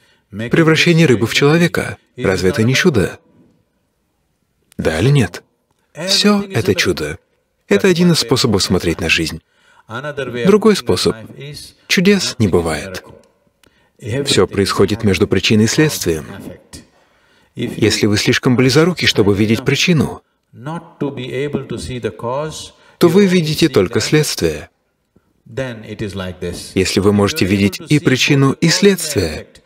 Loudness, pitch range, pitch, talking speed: -14 LUFS, 100-165 Hz, 125 Hz, 105 wpm